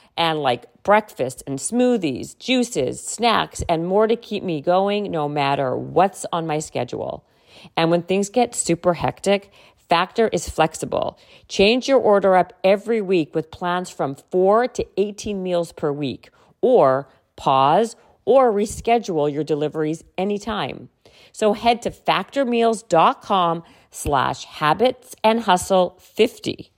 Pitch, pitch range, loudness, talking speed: 185 Hz, 160-220 Hz, -20 LUFS, 130 wpm